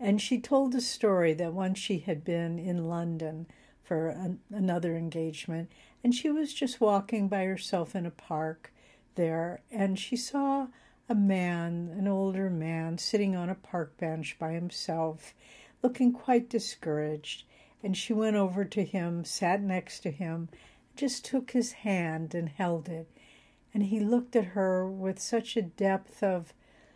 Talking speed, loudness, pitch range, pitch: 160 wpm, -31 LUFS, 170-220 Hz, 190 Hz